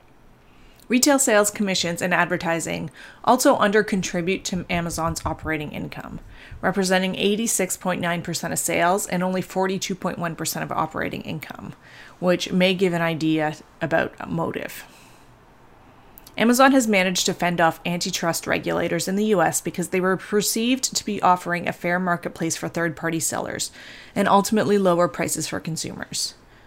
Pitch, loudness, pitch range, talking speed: 180 Hz, -22 LUFS, 170-200 Hz, 135 wpm